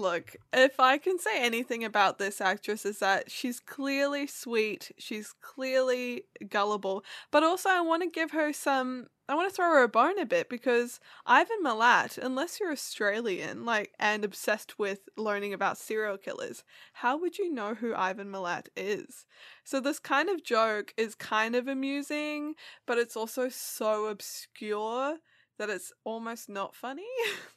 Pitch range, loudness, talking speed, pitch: 215-290 Hz, -30 LUFS, 165 wpm, 245 Hz